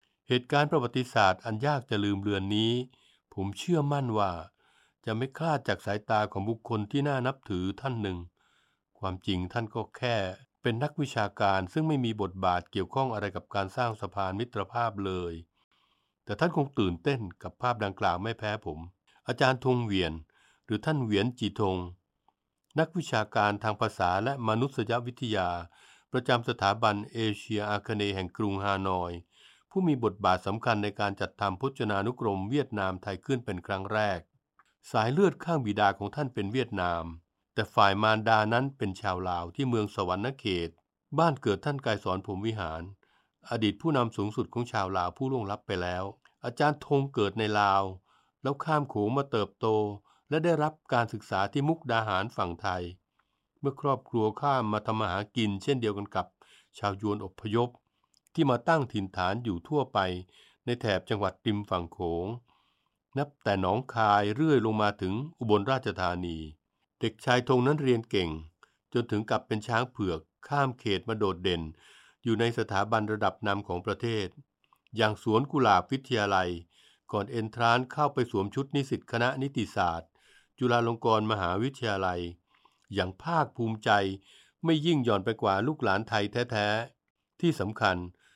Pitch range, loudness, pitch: 100-125 Hz, -30 LUFS, 110 Hz